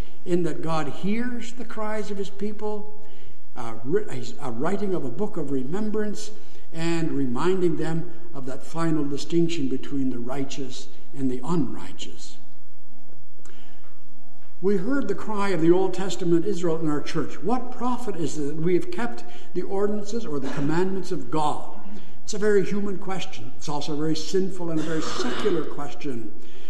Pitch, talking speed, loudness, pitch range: 175 Hz, 160 wpm, -27 LUFS, 155-205 Hz